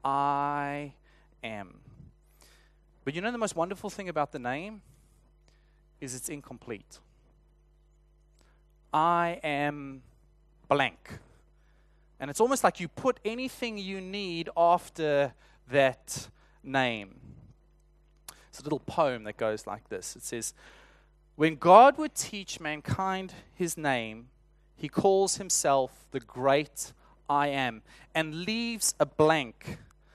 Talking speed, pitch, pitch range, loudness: 115 wpm, 155 Hz, 135-175 Hz, -29 LUFS